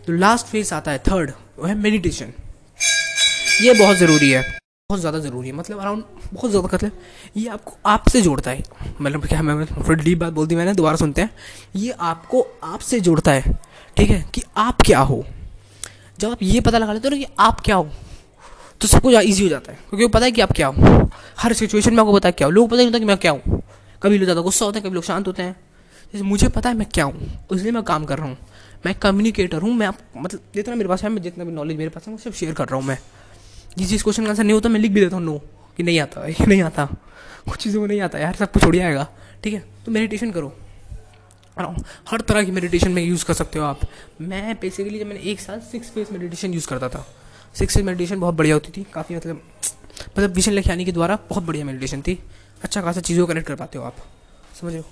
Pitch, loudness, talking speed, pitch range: 180 Hz, -19 LUFS, 250 wpm, 145-210 Hz